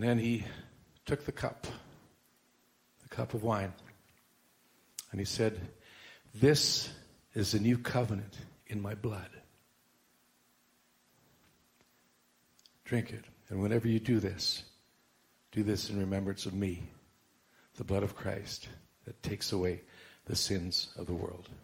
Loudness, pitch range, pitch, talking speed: -34 LUFS, 95-115 Hz, 105 Hz, 130 wpm